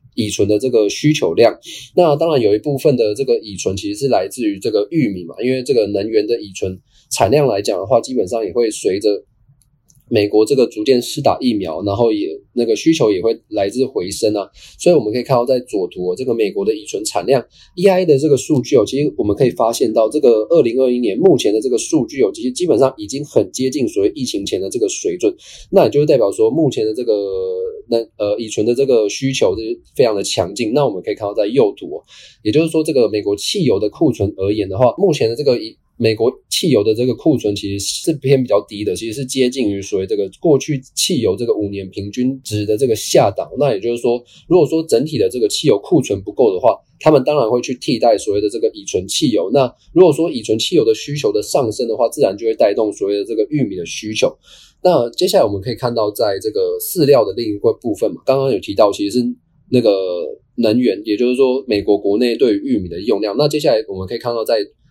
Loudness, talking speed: -16 LUFS, 355 characters per minute